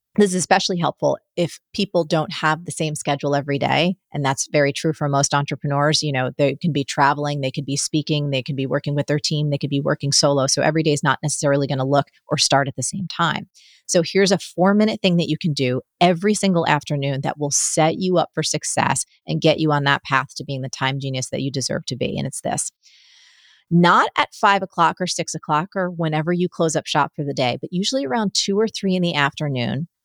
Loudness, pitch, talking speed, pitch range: -20 LUFS, 150 Hz, 240 wpm, 140-175 Hz